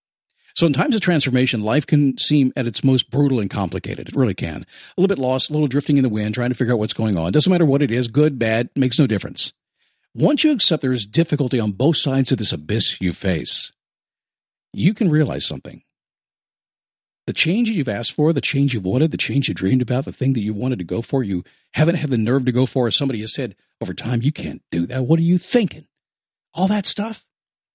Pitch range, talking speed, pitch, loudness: 120-155 Hz, 235 wpm, 135 Hz, -18 LUFS